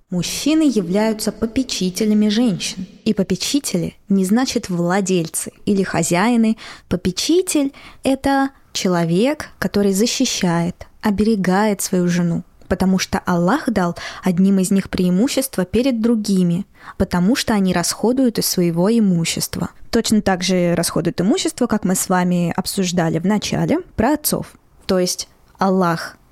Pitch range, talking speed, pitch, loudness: 180-230 Hz, 120 wpm, 195 Hz, -18 LUFS